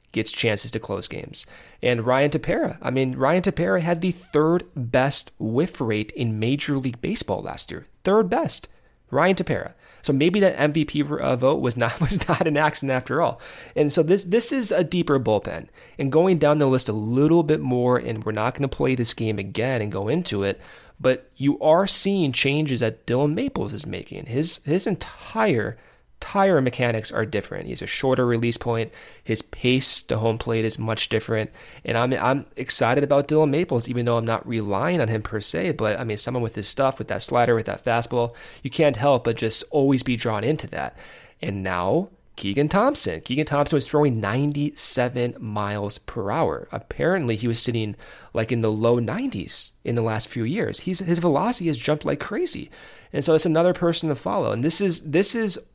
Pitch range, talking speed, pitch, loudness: 115-155 Hz, 200 wpm, 130 Hz, -23 LUFS